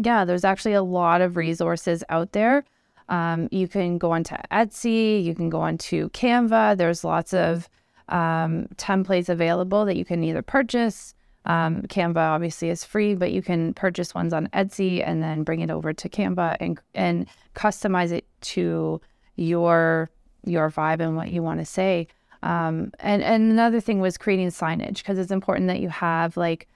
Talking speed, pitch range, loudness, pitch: 175 wpm, 165-200 Hz, -23 LUFS, 175 Hz